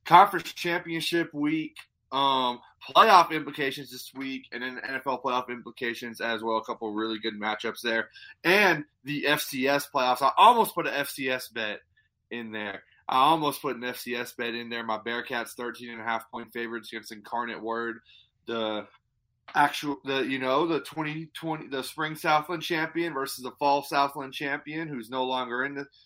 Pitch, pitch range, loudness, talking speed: 130 Hz, 115-145 Hz, -27 LUFS, 175 wpm